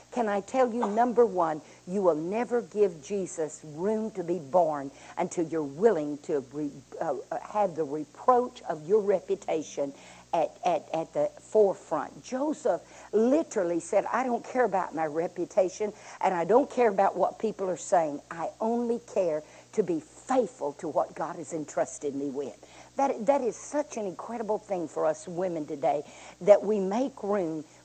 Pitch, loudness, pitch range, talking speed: 190 Hz, -29 LUFS, 160-225 Hz, 170 wpm